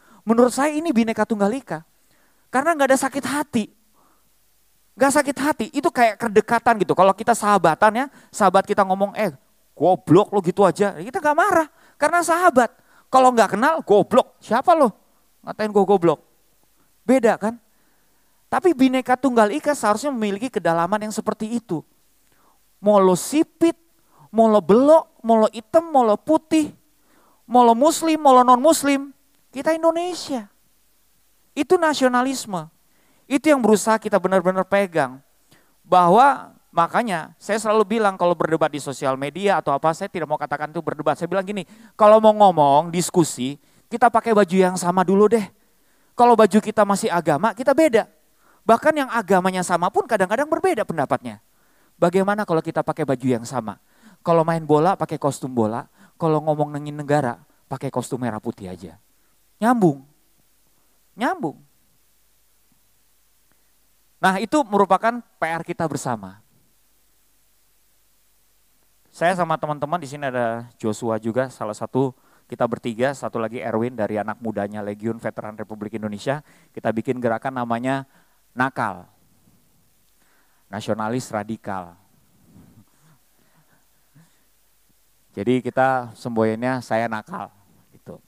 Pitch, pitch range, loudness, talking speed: 195 Hz, 140-235 Hz, -20 LUFS, 130 wpm